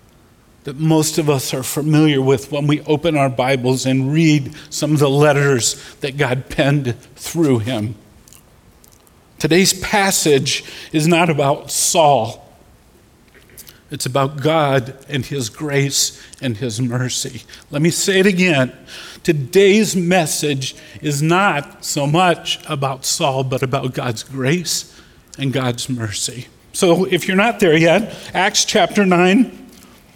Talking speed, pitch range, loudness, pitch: 135 wpm, 135-170 Hz, -16 LUFS, 145 Hz